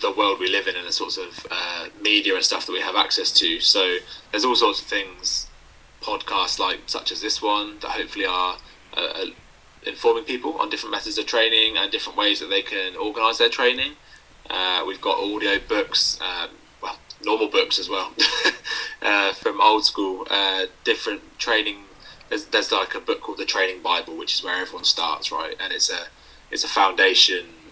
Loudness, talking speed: -21 LUFS, 195 wpm